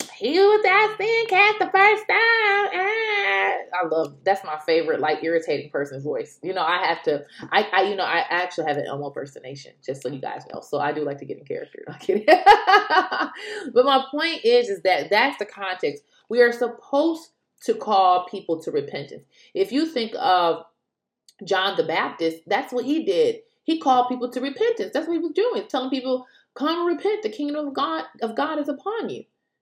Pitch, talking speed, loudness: 300 Hz, 200 wpm, -21 LUFS